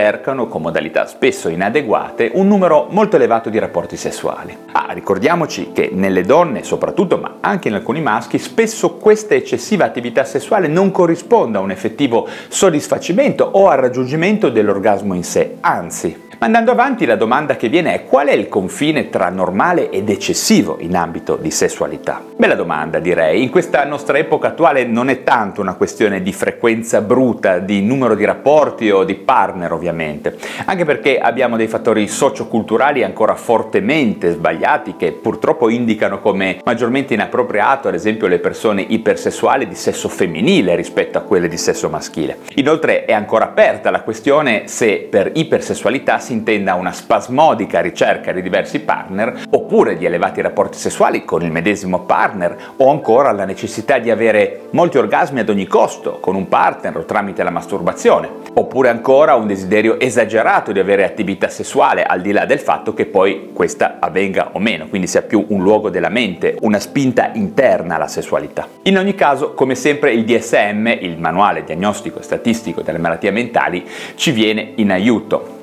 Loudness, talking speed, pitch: -15 LUFS, 165 wpm, 175 Hz